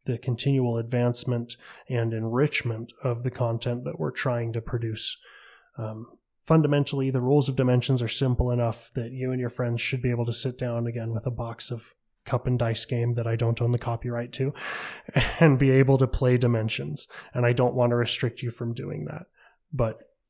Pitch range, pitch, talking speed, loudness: 115-130 Hz, 120 Hz, 195 wpm, -26 LUFS